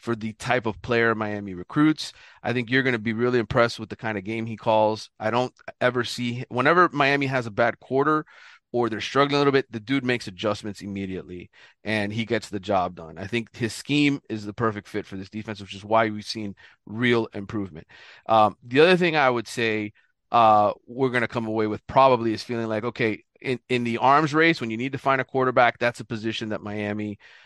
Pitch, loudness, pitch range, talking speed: 115 Hz, -24 LUFS, 105-125 Hz, 225 wpm